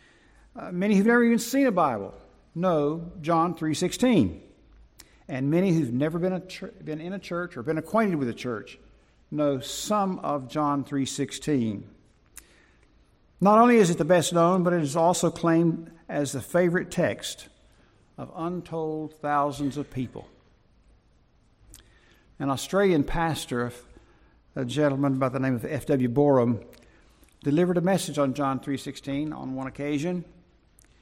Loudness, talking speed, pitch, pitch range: -25 LUFS, 145 wpm, 150 Hz, 135-175 Hz